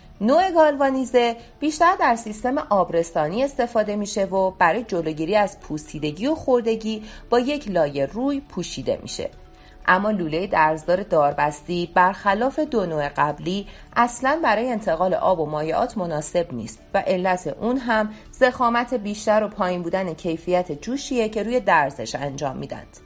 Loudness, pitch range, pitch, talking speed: -22 LUFS, 170-245 Hz, 205 Hz, 140 wpm